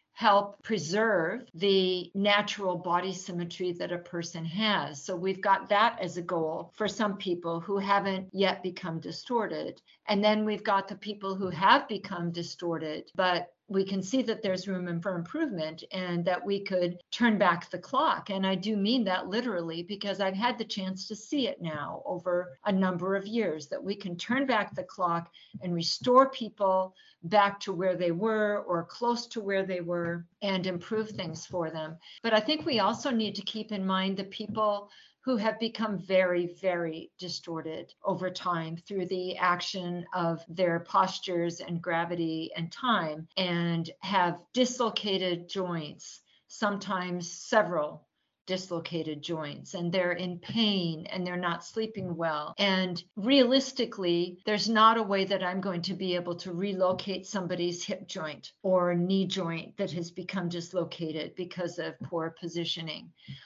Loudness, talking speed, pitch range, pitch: -30 LUFS, 165 wpm, 175-205 Hz, 185 Hz